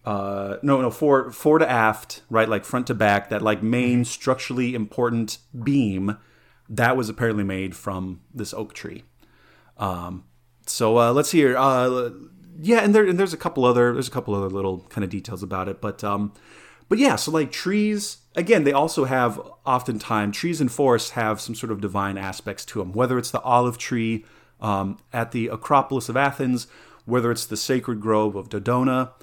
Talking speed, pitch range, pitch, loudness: 190 wpm, 105-130 Hz, 120 Hz, -22 LUFS